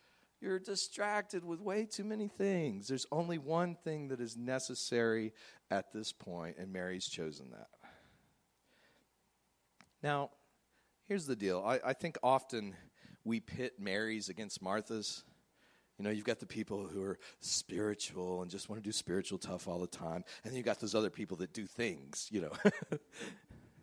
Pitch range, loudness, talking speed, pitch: 100-165 Hz, -39 LUFS, 165 wpm, 115 Hz